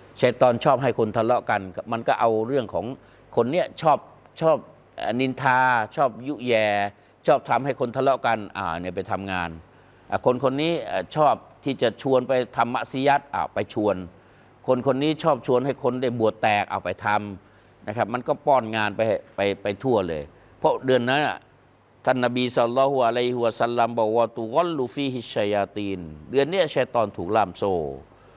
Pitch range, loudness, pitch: 100-130 Hz, -24 LUFS, 115 Hz